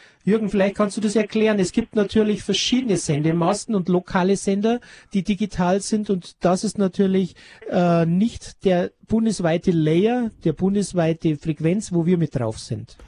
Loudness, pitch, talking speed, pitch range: -21 LUFS, 195 Hz, 155 wpm, 170-210 Hz